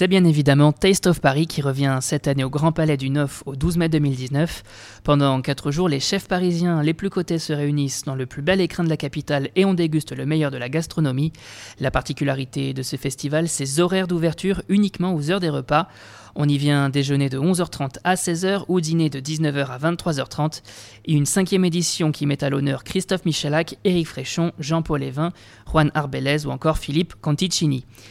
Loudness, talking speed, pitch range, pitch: -21 LUFS, 200 wpm, 140-170 Hz, 150 Hz